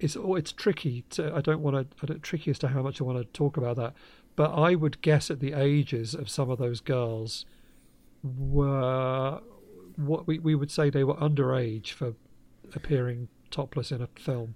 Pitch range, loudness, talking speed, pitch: 125-150 Hz, -29 LUFS, 190 wpm, 140 Hz